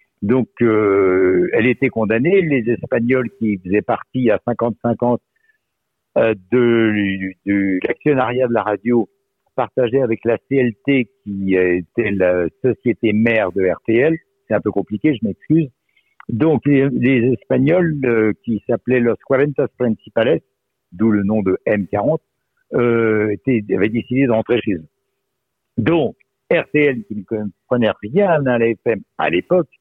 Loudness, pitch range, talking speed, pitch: -17 LUFS, 105-130 Hz, 135 wpm, 115 Hz